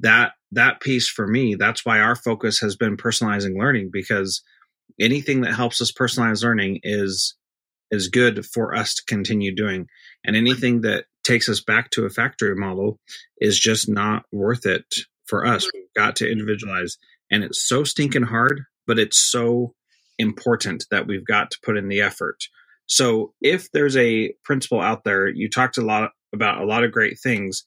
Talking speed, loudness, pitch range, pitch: 180 wpm, -20 LUFS, 105-120 Hz, 110 Hz